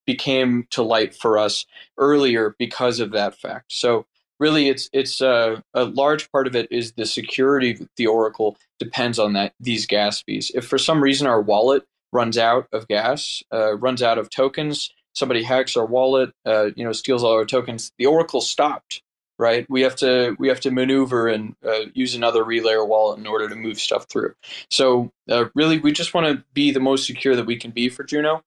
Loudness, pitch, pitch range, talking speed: -20 LUFS, 120 Hz, 110-135 Hz, 205 wpm